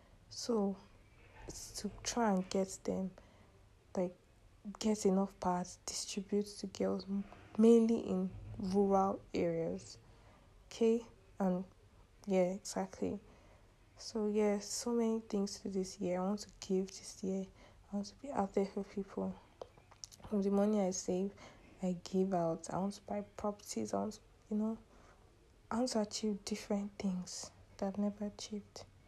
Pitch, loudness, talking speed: 190 Hz, -37 LUFS, 150 wpm